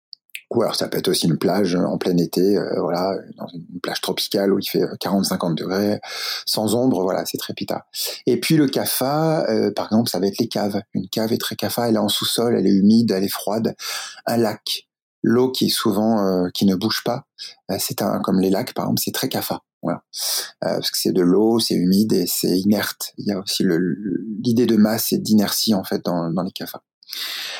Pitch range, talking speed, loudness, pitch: 100-120 Hz, 230 wpm, -20 LUFS, 110 Hz